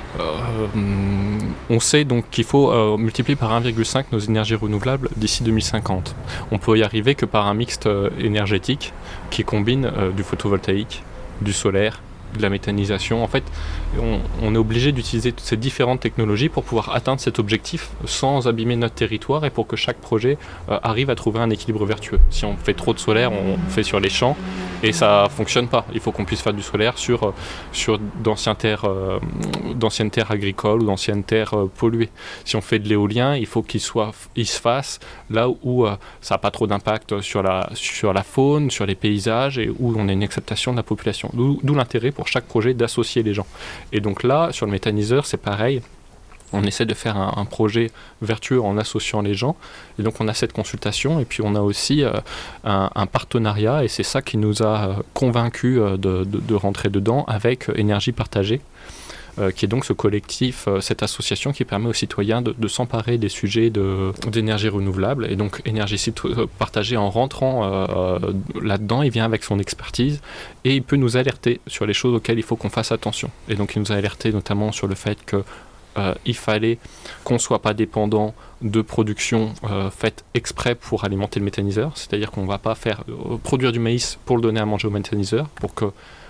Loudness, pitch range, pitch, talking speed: -21 LUFS, 100-120 Hz, 110 Hz, 200 wpm